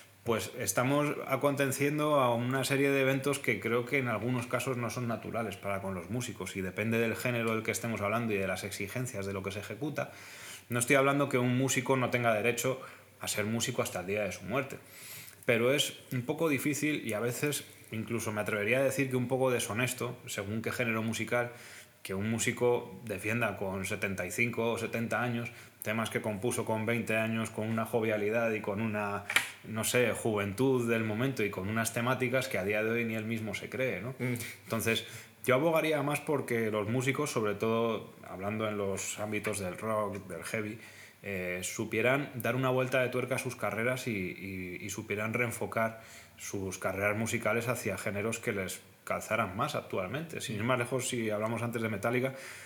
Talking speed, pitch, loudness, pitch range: 195 wpm, 115 Hz, -32 LUFS, 105-125 Hz